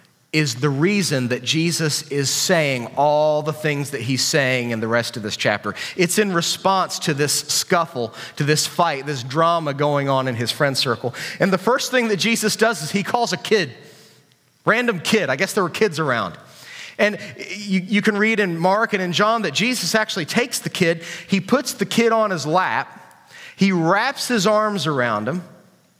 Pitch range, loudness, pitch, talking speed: 145-205 Hz, -19 LUFS, 170 Hz, 195 wpm